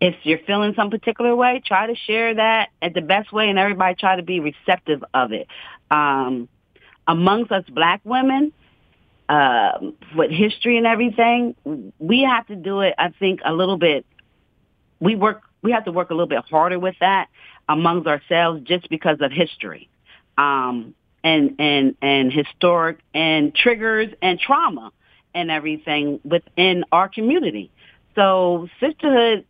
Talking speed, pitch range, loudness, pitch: 155 wpm, 160-225 Hz, -19 LUFS, 185 Hz